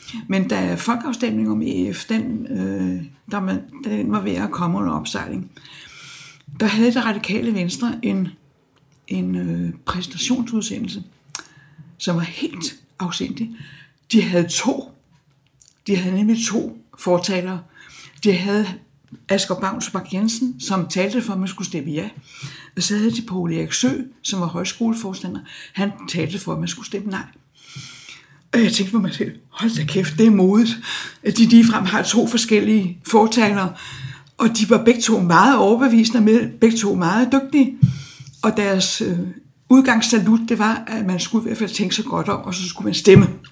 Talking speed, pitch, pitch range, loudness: 165 wpm, 195 Hz, 165-225 Hz, -19 LUFS